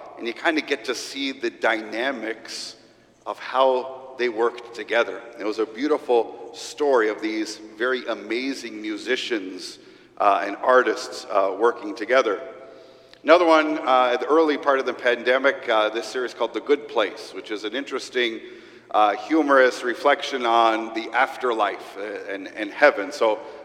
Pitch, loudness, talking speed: 165 Hz, -22 LUFS, 155 wpm